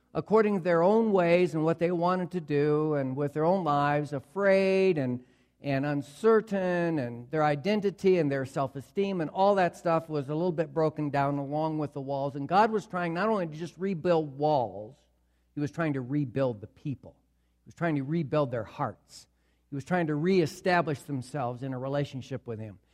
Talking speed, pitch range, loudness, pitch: 200 wpm, 140-180 Hz, -28 LUFS, 150 Hz